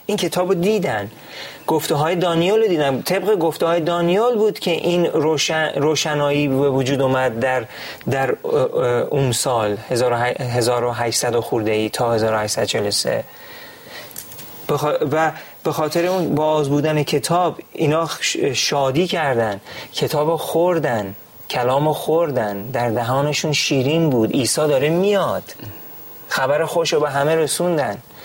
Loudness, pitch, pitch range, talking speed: -19 LUFS, 150 Hz, 130-170 Hz, 120 wpm